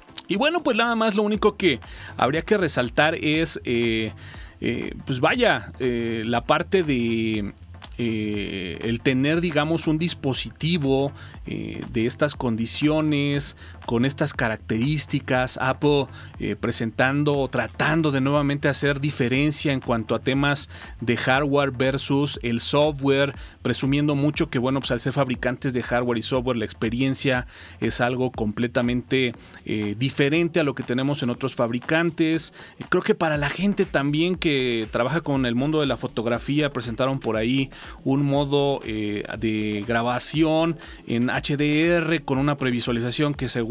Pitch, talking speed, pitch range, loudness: 130 Hz, 145 wpm, 115-150 Hz, -23 LUFS